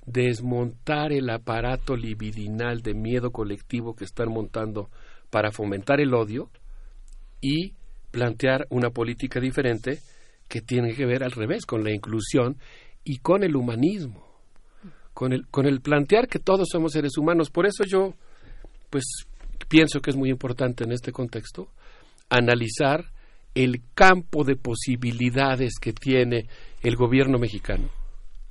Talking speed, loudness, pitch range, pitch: 135 wpm, -24 LUFS, 115-140 Hz, 125 Hz